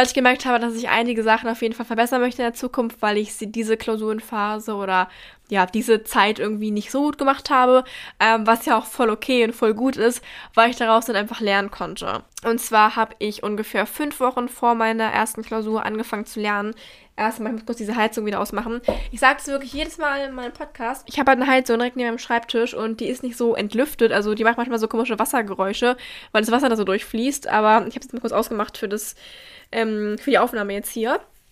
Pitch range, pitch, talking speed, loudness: 215-245 Hz, 230 Hz, 230 wpm, -21 LUFS